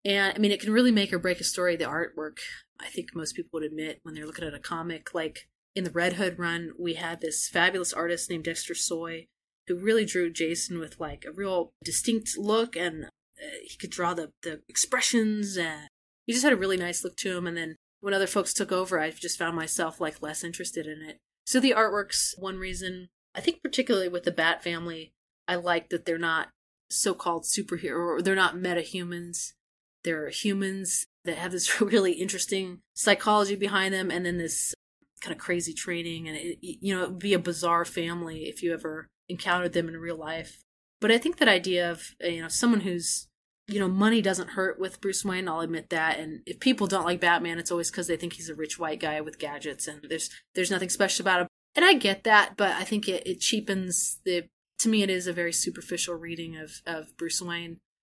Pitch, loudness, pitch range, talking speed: 175 Hz, -27 LUFS, 165-195 Hz, 220 wpm